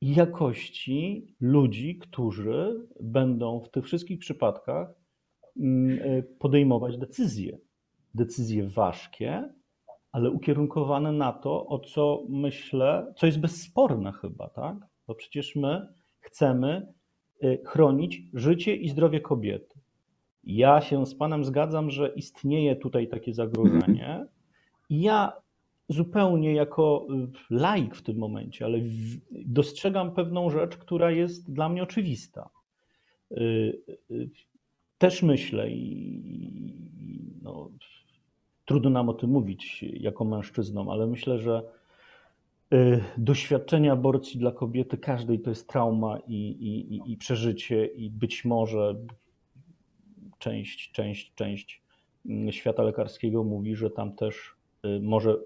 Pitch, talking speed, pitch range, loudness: 130 Hz, 105 wpm, 115-150 Hz, -27 LUFS